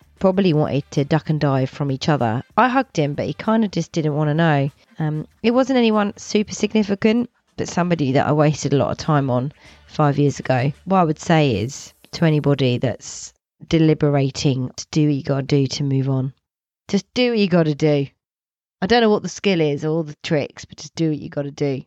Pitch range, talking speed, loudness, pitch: 140-180 Hz, 225 wpm, -19 LUFS, 150 Hz